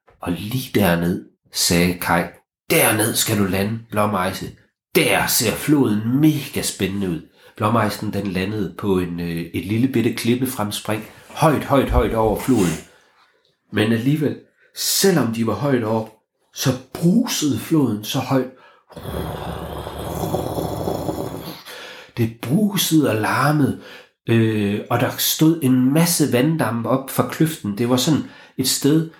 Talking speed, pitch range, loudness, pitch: 125 wpm, 105-140 Hz, -20 LUFS, 120 Hz